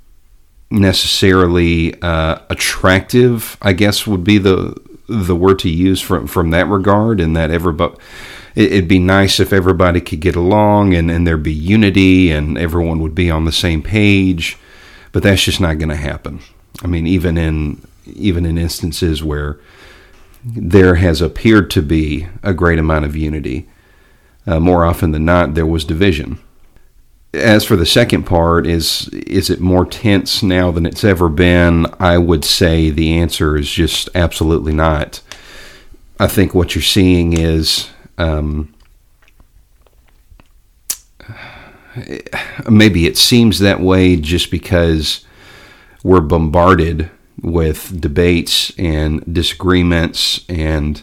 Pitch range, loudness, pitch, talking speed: 80-95 Hz, -13 LUFS, 85 Hz, 140 wpm